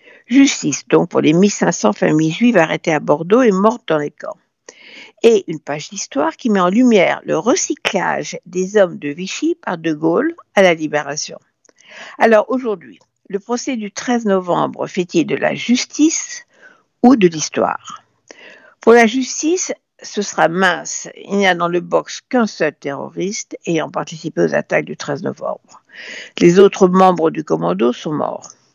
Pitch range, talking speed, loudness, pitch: 165-250 Hz, 165 wpm, -16 LUFS, 200 Hz